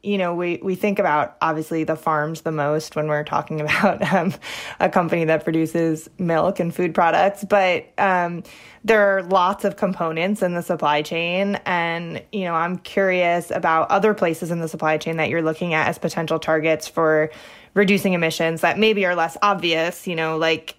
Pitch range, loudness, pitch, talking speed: 160-190 Hz, -20 LUFS, 170 Hz, 190 wpm